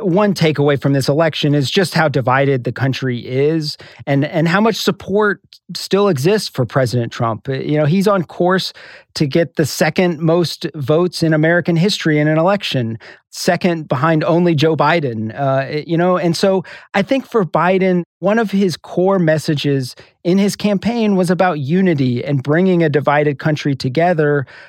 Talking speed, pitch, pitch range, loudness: 170 wpm, 160 Hz, 145-185 Hz, -16 LUFS